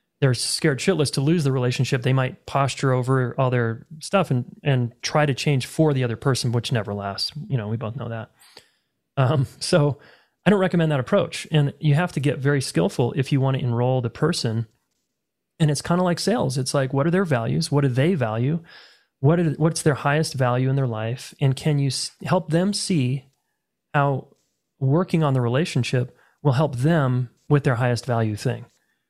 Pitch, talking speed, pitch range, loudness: 140 Hz, 200 wpm, 125-155 Hz, -22 LUFS